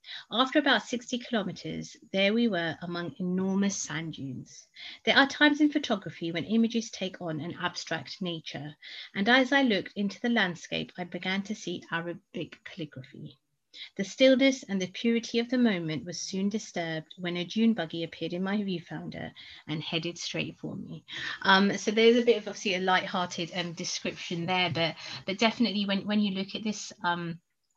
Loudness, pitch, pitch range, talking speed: -28 LUFS, 185 Hz, 165-225 Hz, 175 wpm